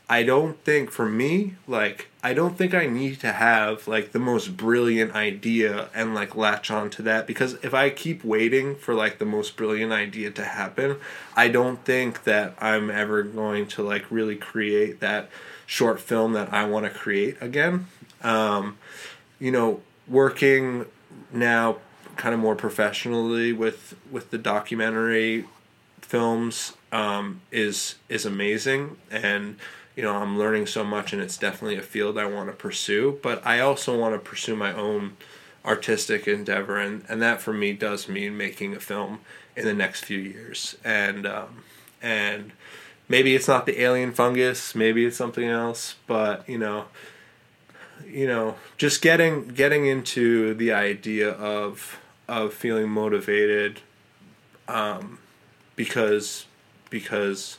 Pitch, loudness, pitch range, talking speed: 110 Hz, -24 LUFS, 105-130 Hz, 155 wpm